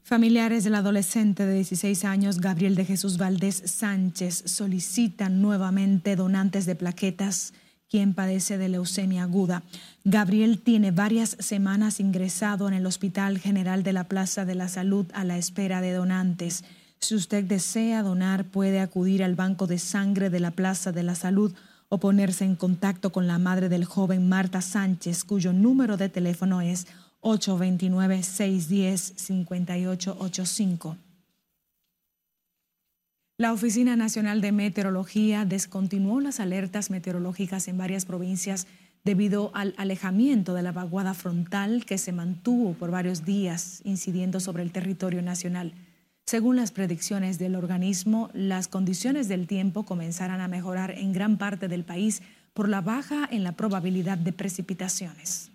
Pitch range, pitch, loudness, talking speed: 185-200 Hz, 190 Hz, -26 LUFS, 140 wpm